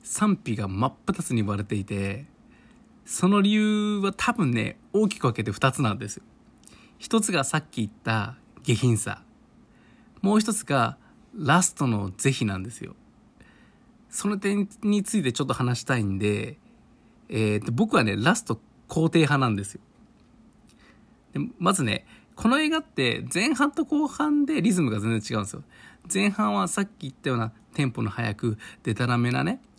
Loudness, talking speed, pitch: -25 LUFS, 290 characters per minute, 150 Hz